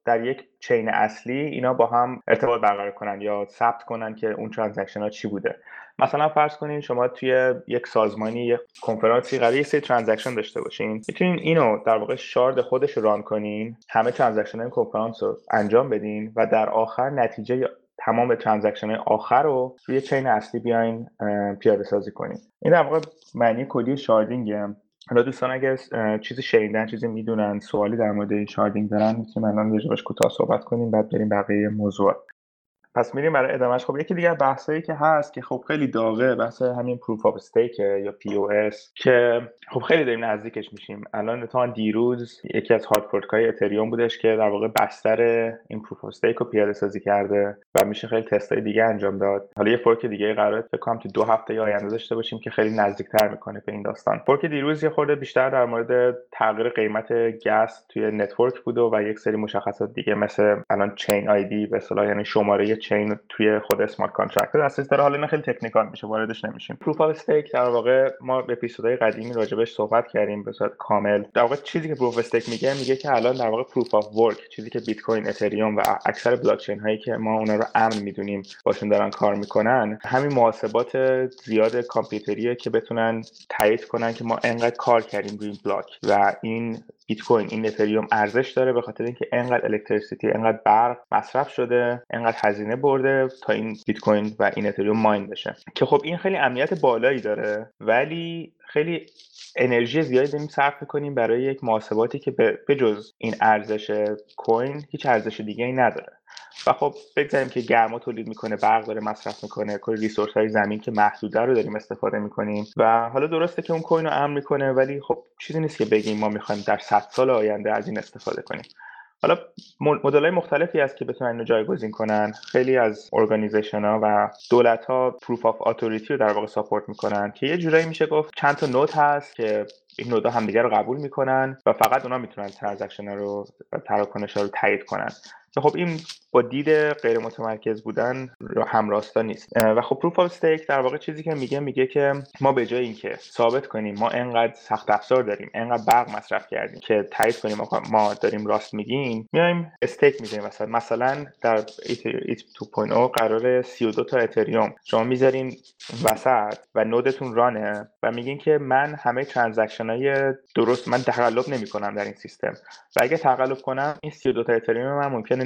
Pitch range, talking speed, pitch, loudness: 105-130 Hz, 185 wpm, 115 Hz, -23 LUFS